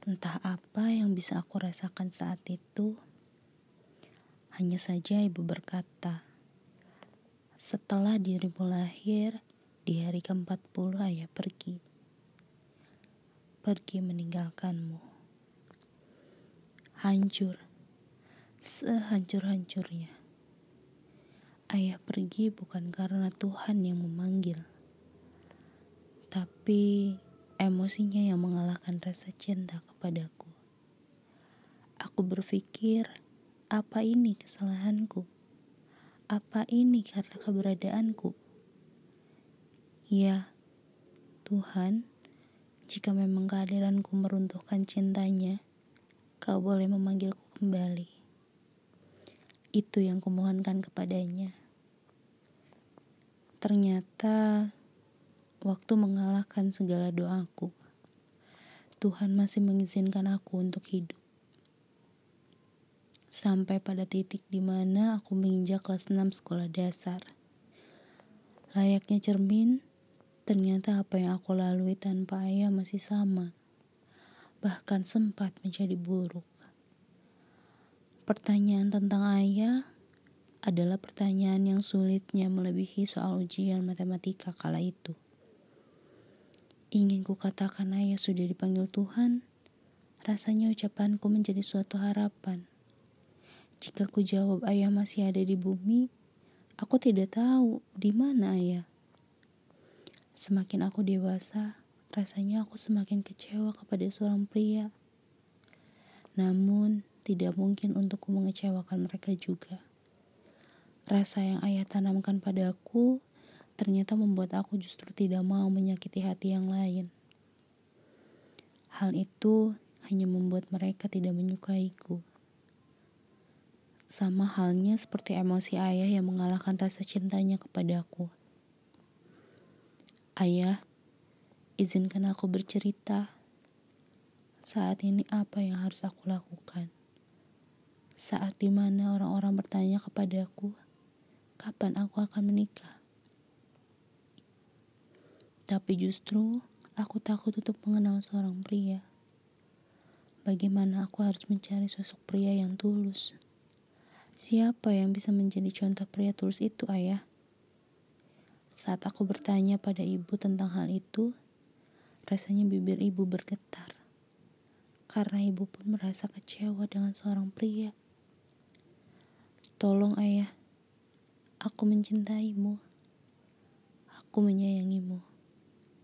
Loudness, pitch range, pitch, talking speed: -32 LUFS, 185-205 Hz, 195 Hz, 90 wpm